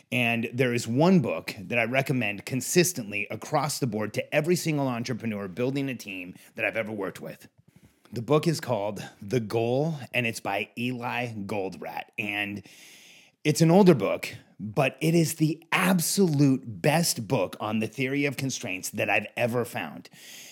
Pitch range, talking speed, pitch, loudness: 110-150 Hz, 165 wpm, 125 Hz, -26 LUFS